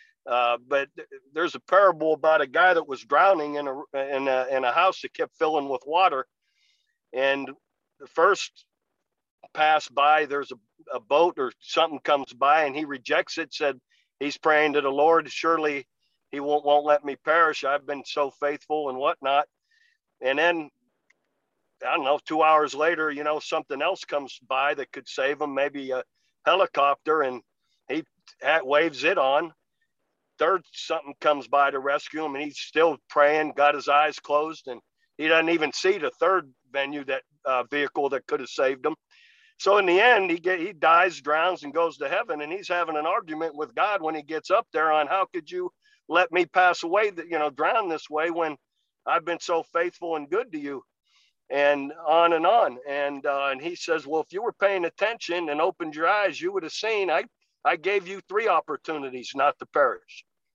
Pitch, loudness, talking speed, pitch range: 155 Hz, -24 LUFS, 195 wpm, 145-185 Hz